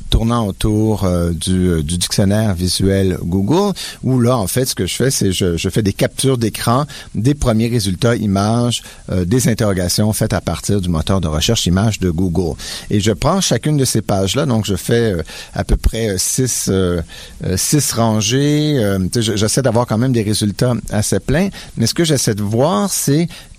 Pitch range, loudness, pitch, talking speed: 95-125 Hz, -16 LUFS, 110 Hz, 190 wpm